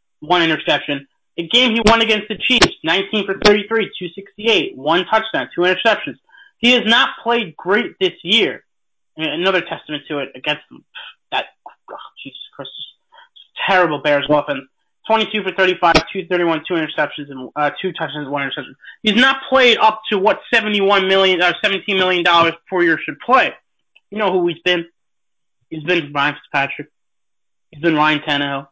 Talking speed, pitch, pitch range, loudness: 165 wpm, 185 Hz, 155-215 Hz, -16 LUFS